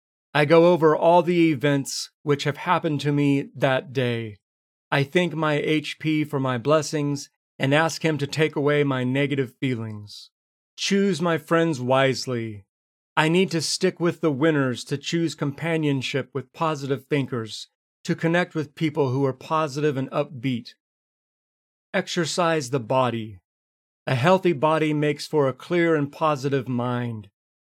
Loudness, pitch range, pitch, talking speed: -23 LUFS, 130-160 Hz, 145 Hz, 145 wpm